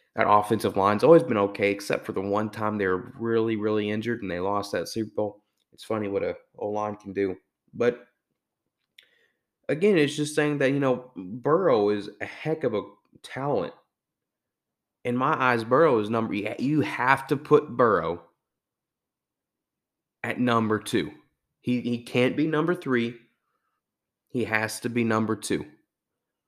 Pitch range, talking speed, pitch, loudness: 105-130 Hz, 160 wpm, 115 Hz, -25 LUFS